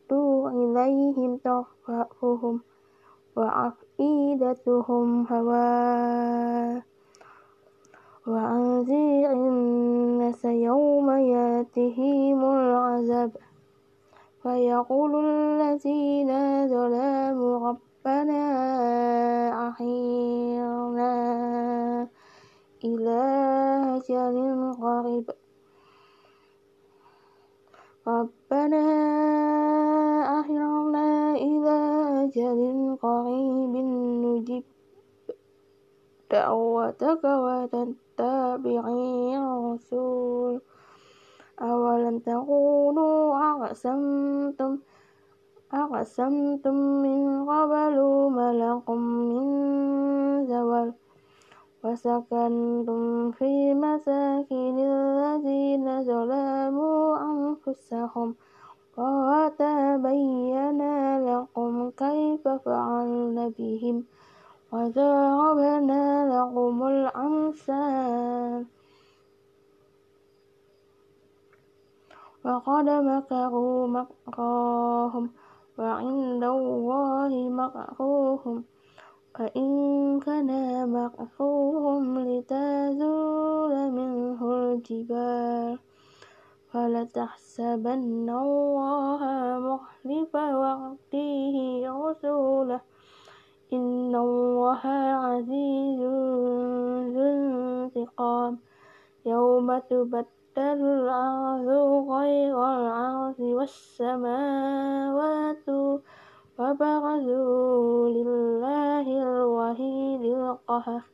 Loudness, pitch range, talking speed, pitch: -26 LUFS, 240-280 Hz, 45 wpm, 260 Hz